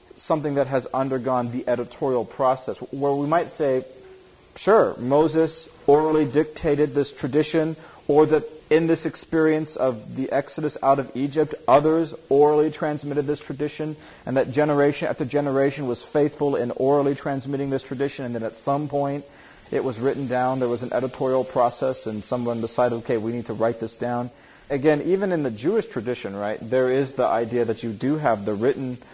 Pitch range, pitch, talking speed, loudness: 125-150 Hz, 140 Hz, 175 wpm, -23 LUFS